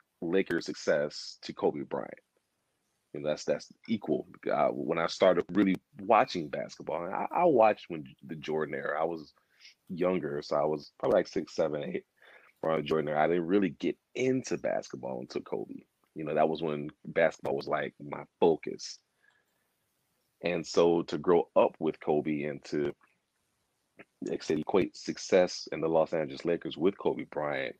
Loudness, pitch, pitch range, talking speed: -31 LUFS, 80 Hz, 75-85 Hz, 165 wpm